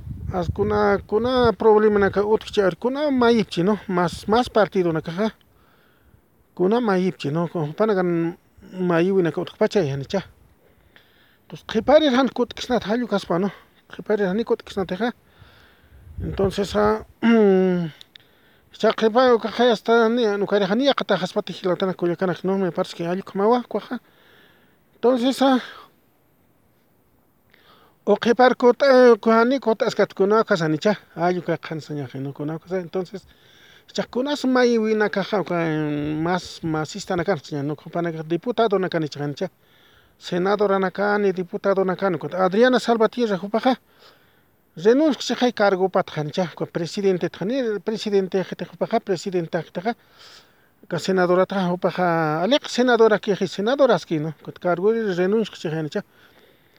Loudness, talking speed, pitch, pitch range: -21 LUFS, 90 wpm, 195 Hz, 175-225 Hz